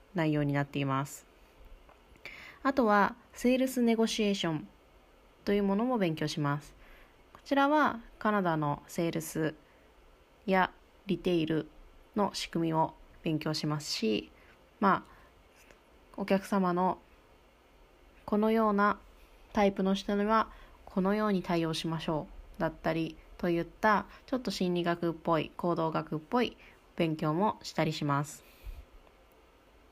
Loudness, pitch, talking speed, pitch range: -31 LUFS, 175 Hz, 260 characters per minute, 155-205 Hz